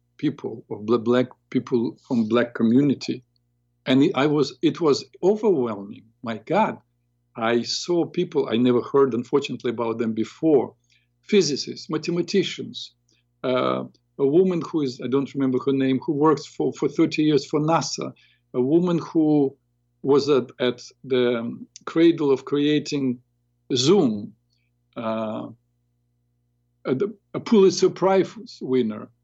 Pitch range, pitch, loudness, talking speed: 120-150 Hz, 125 Hz, -22 LUFS, 125 wpm